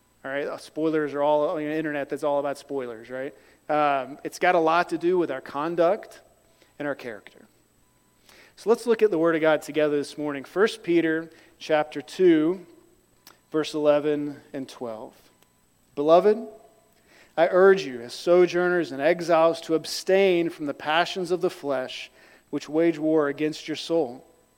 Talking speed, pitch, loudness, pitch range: 165 wpm, 155 Hz, -24 LUFS, 145-175 Hz